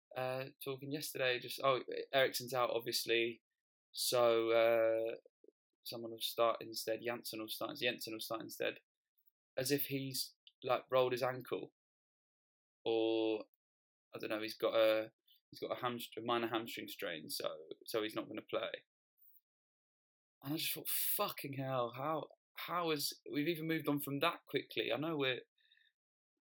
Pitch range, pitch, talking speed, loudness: 115-155 Hz, 130 Hz, 155 wpm, -38 LUFS